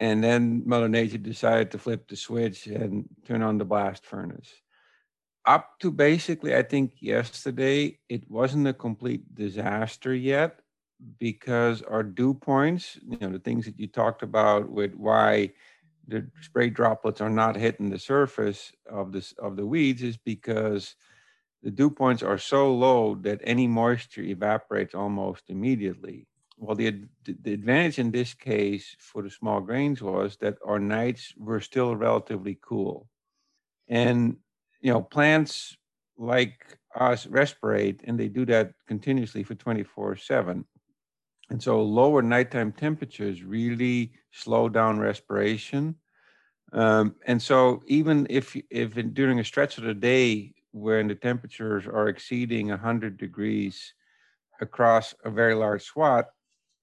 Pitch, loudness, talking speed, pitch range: 115 Hz, -26 LUFS, 145 wpm, 105-125 Hz